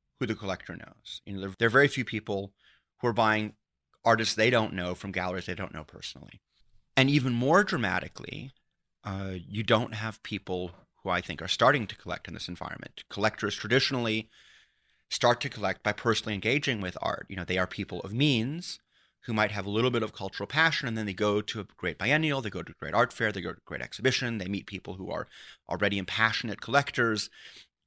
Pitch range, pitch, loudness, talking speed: 95-120 Hz, 110 Hz, -29 LUFS, 210 wpm